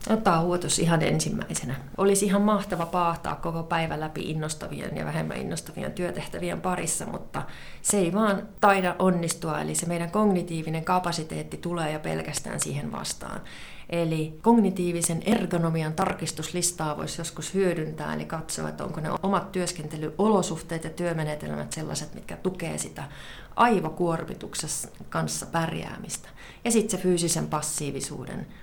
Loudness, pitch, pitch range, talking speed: -27 LUFS, 170 Hz, 155-185 Hz, 130 wpm